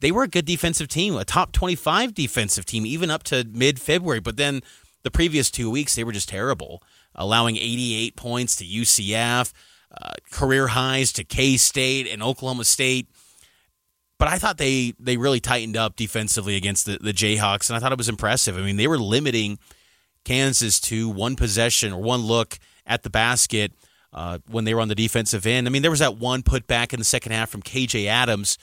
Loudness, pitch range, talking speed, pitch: -21 LUFS, 110-130 Hz, 200 wpm, 120 Hz